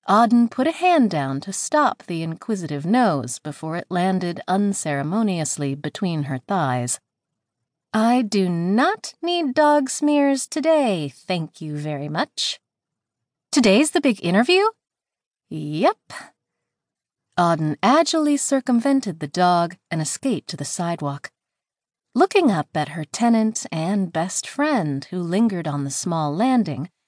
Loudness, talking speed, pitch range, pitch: -21 LUFS, 125 wpm, 150-255 Hz, 185 Hz